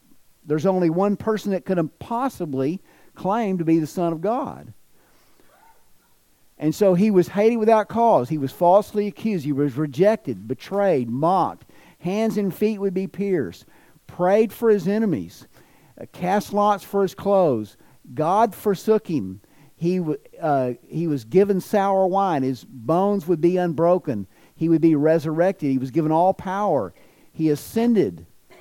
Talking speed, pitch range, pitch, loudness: 150 wpm, 160-205 Hz, 185 Hz, -21 LUFS